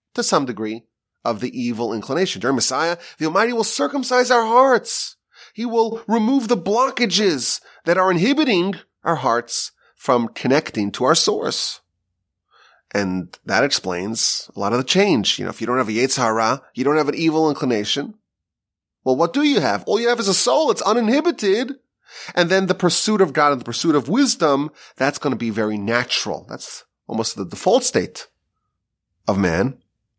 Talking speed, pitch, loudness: 175 wpm, 155 Hz, -19 LUFS